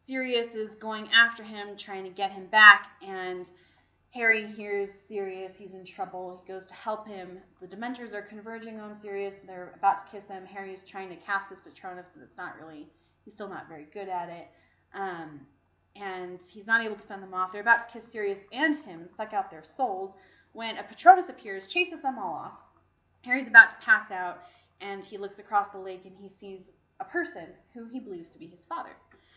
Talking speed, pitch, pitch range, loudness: 205 wpm, 200 Hz, 185-225 Hz, -25 LUFS